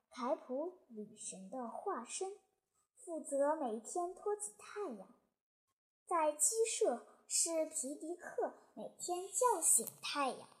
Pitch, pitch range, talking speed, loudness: 335 Hz, 280-390 Hz, 160 characters per minute, -38 LUFS